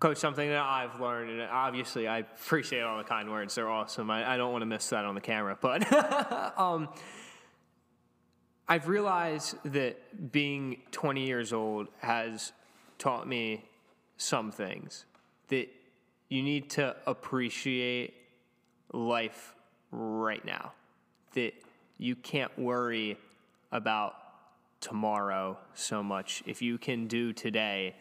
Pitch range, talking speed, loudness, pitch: 110-140 Hz, 130 wpm, -33 LUFS, 120 Hz